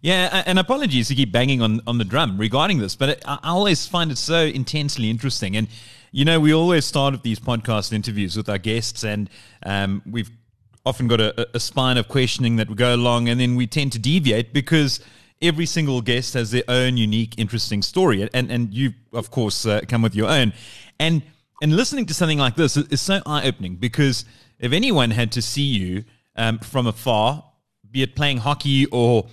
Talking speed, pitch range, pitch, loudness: 205 wpm, 115-145 Hz, 125 Hz, -20 LUFS